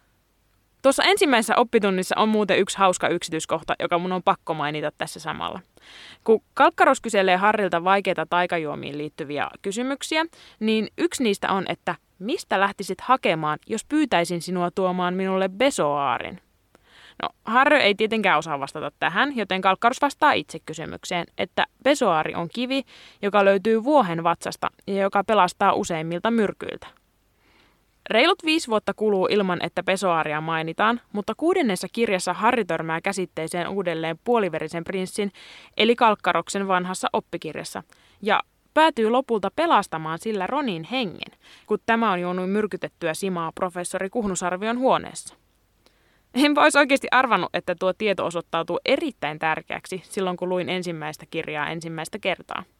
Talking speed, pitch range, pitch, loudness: 130 wpm, 170-225 Hz, 190 Hz, -23 LUFS